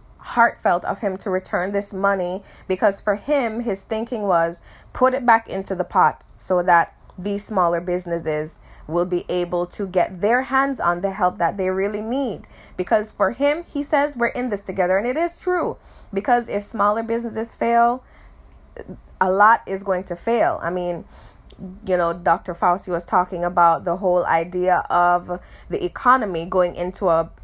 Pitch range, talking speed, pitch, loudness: 175-225 Hz, 175 wpm, 190 Hz, -21 LUFS